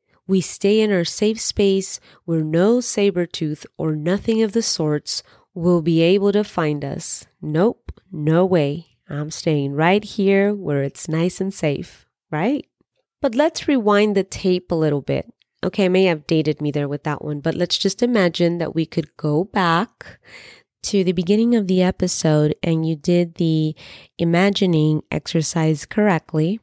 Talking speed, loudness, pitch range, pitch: 165 wpm, -20 LUFS, 155-200 Hz, 175 Hz